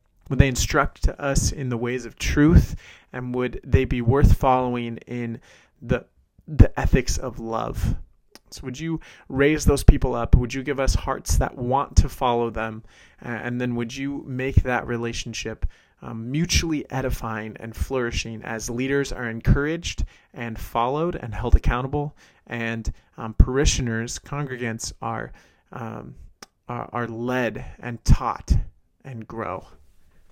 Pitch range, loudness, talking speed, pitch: 115-130 Hz, -24 LUFS, 140 wpm, 120 Hz